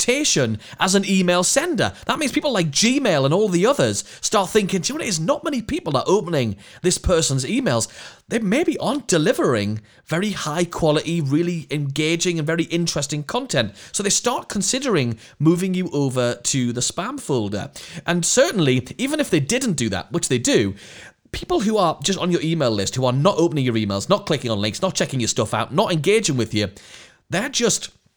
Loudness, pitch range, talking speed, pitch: -20 LUFS, 125-200 Hz, 195 wpm, 165 Hz